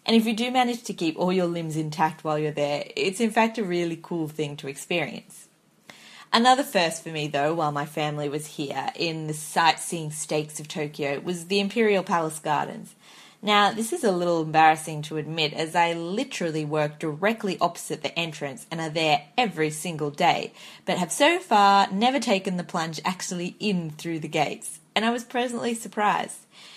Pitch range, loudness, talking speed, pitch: 155-200 Hz, -25 LUFS, 190 wpm, 170 Hz